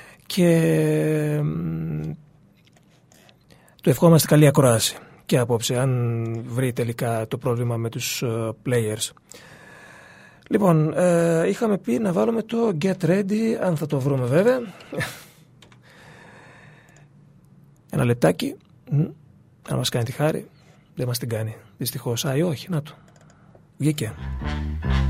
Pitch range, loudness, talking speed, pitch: 120-165 Hz, -22 LUFS, 110 wpm, 150 Hz